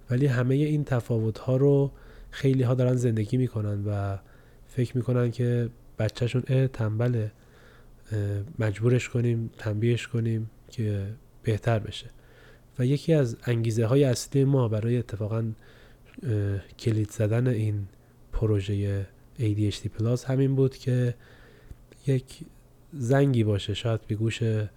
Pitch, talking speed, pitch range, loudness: 120 Hz, 120 wpm, 110-125 Hz, -27 LUFS